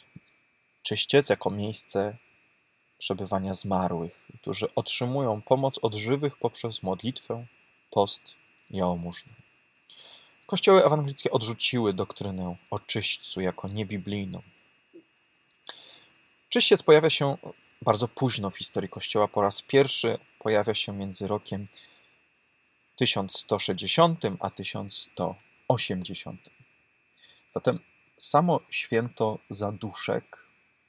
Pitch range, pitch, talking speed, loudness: 100-130 Hz, 110 Hz, 85 wpm, -25 LUFS